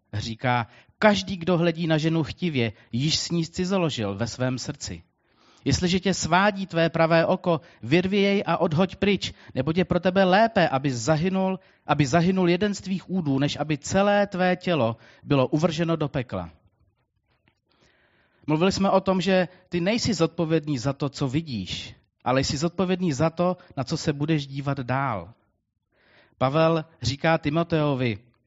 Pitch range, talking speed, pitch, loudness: 130-180 Hz, 155 wpm, 160 Hz, -24 LUFS